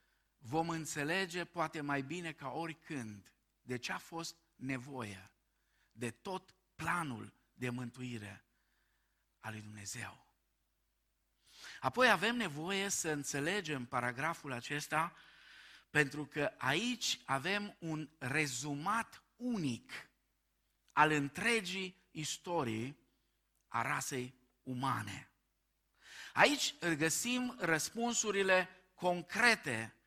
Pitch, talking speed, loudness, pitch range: 155 Hz, 90 wpm, -36 LUFS, 125-185 Hz